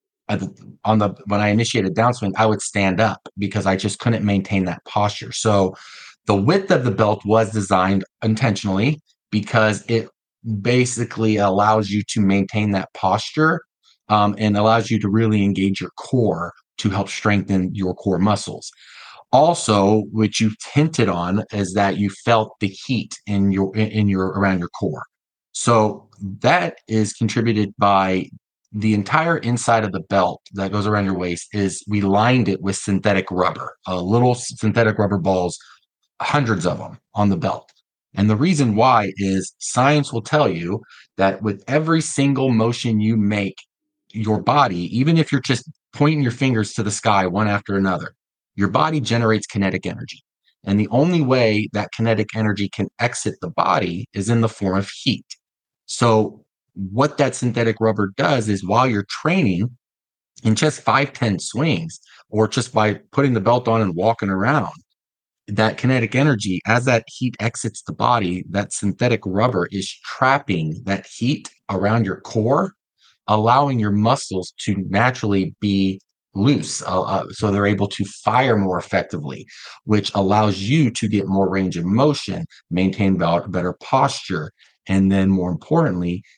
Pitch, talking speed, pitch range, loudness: 105 Hz, 160 wpm, 95-115 Hz, -19 LUFS